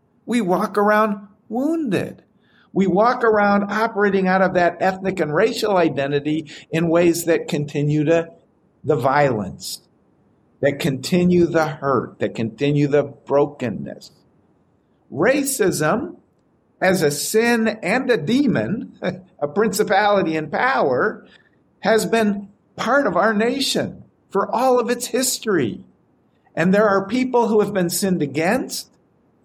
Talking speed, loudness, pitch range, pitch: 125 wpm, -19 LUFS, 160-225 Hz, 195 Hz